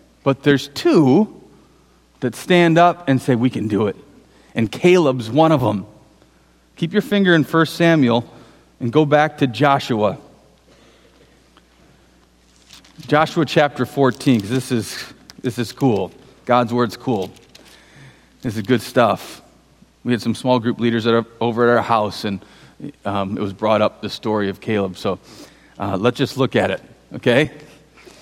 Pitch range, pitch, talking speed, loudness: 105-140 Hz, 120 Hz, 155 wpm, -18 LUFS